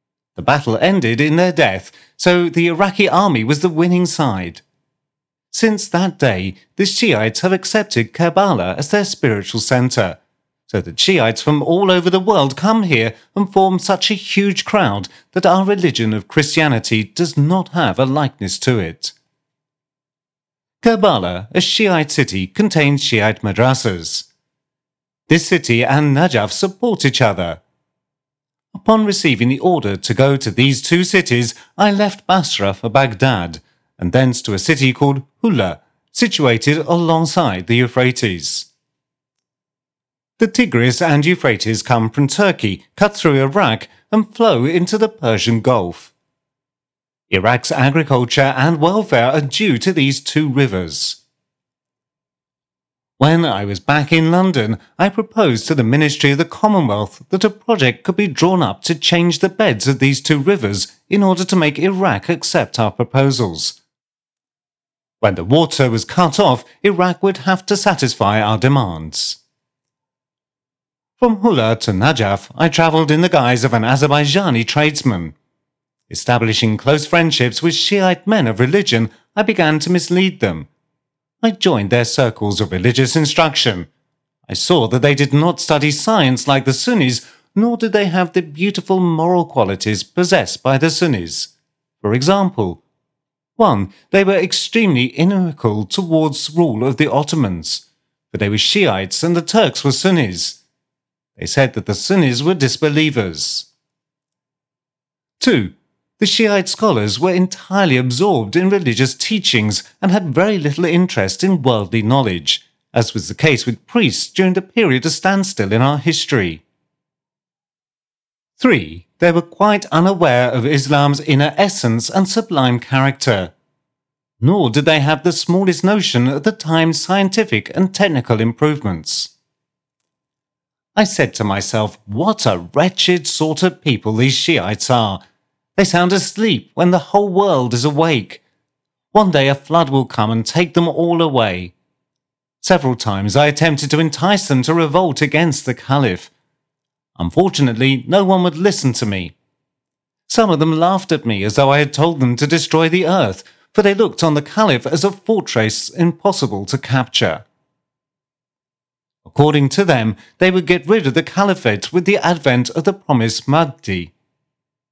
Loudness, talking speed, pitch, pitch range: -15 LUFS, 150 wpm, 150 Hz, 120-180 Hz